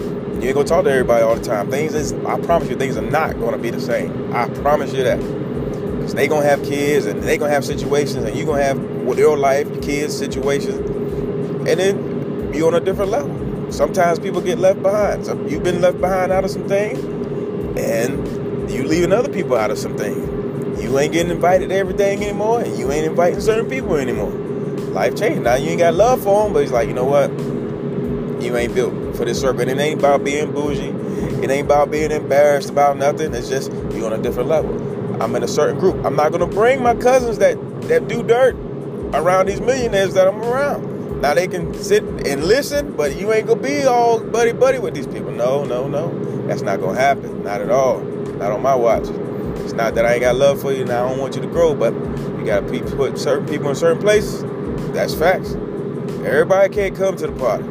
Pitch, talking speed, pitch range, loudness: 175 Hz, 225 wpm, 140-205 Hz, -18 LUFS